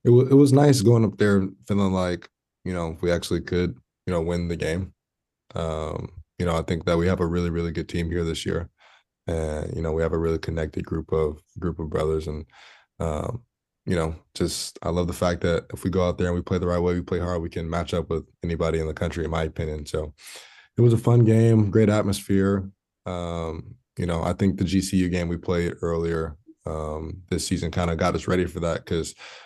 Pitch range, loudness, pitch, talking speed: 80-95 Hz, -24 LUFS, 85 Hz, 235 wpm